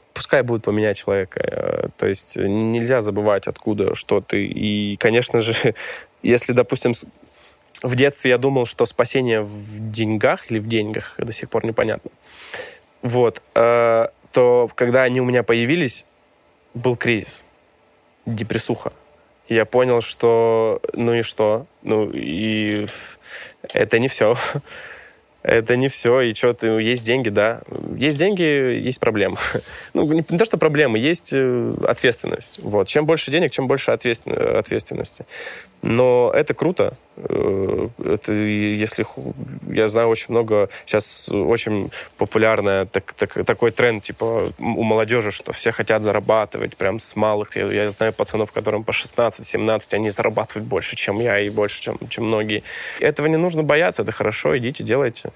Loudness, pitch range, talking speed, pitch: -20 LUFS, 110-130 Hz, 140 wpm, 115 Hz